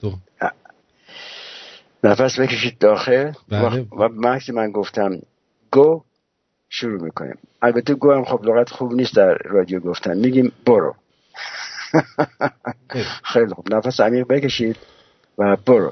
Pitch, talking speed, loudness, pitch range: 120 Hz, 105 wpm, -18 LUFS, 105-130 Hz